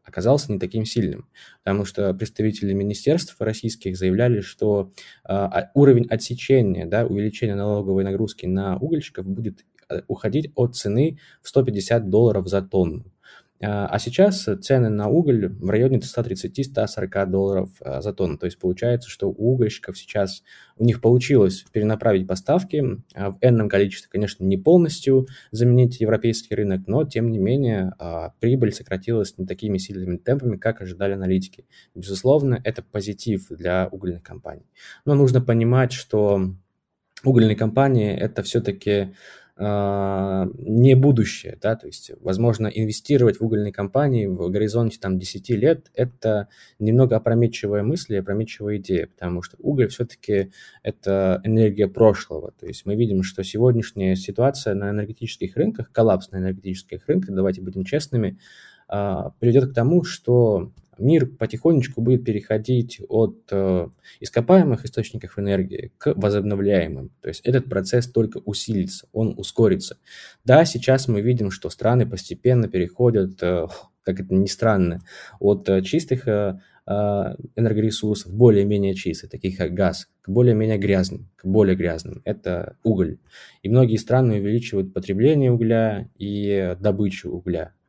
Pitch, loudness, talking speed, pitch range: 105 Hz, -21 LUFS, 135 wpm, 95-120 Hz